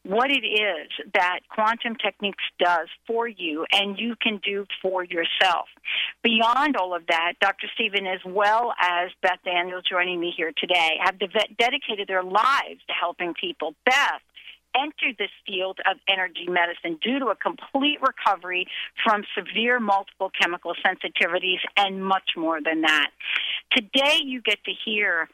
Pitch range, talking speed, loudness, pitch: 180-225 Hz, 150 wpm, -23 LUFS, 195 Hz